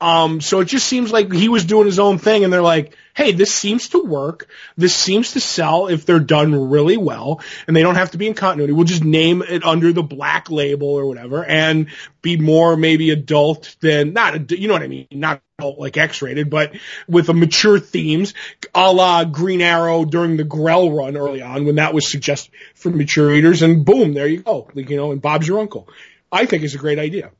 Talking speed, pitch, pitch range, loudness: 230 wpm, 165 Hz, 150-185 Hz, -15 LUFS